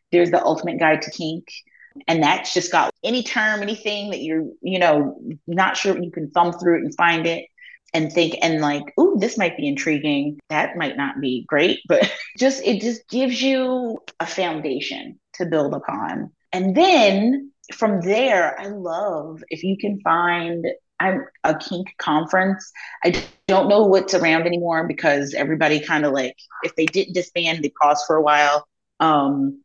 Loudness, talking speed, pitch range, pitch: -20 LUFS, 180 wpm, 155-205 Hz, 175 Hz